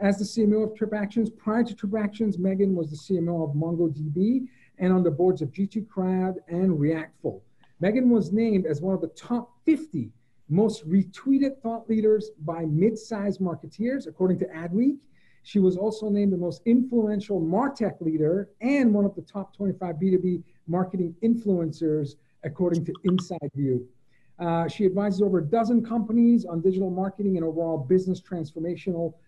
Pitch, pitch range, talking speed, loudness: 190 Hz, 170-215 Hz, 160 wpm, -25 LUFS